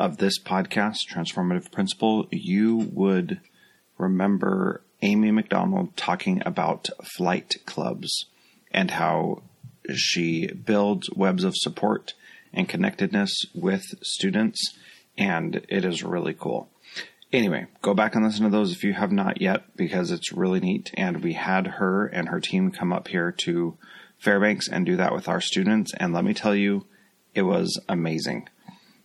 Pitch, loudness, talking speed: 170 Hz, -25 LUFS, 150 wpm